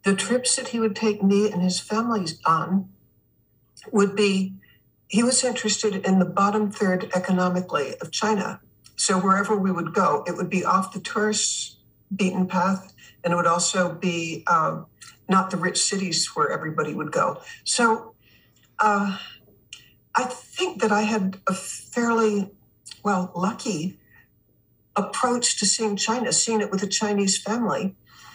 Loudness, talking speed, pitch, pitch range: -23 LUFS, 150 wpm, 200 Hz, 185-220 Hz